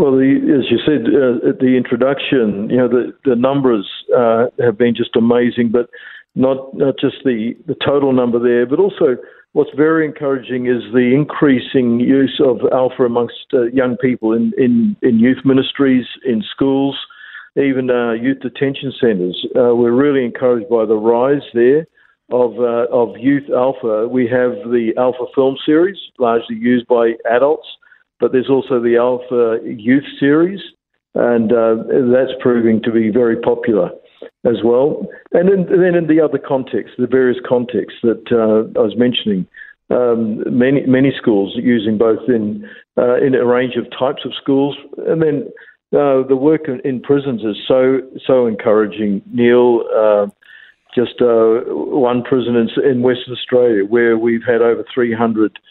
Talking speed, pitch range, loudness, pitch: 165 wpm, 120-135 Hz, -15 LUFS, 125 Hz